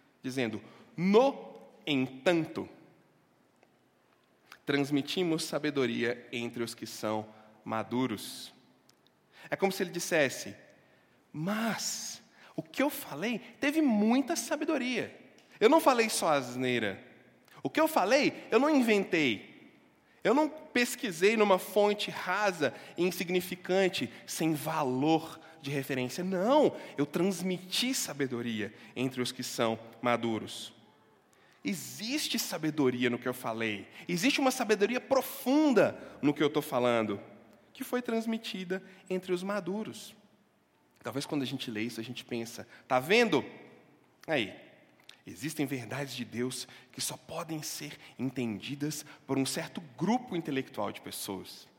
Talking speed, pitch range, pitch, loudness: 120 wpm, 125-210 Hz, 160 Hz, -31 LUFS